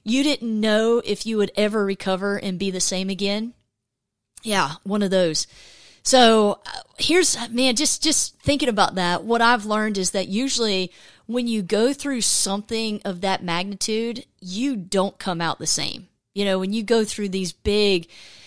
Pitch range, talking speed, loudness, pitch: 190-230 Hz, 170 wpm, -21 LUFS, 205 Hz